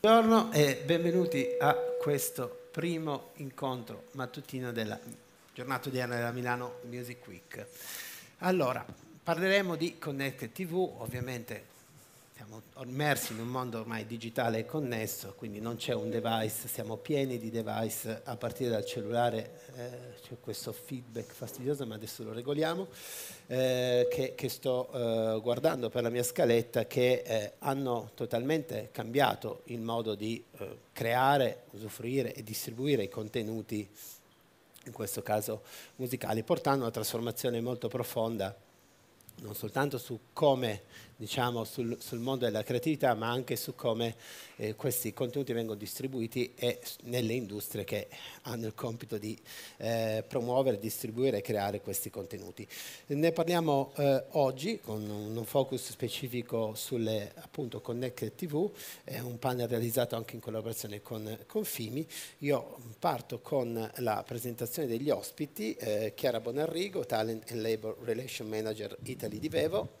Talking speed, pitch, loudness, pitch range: 140 wpm, 120 Hz, -34 LUFS, 115-135 Hz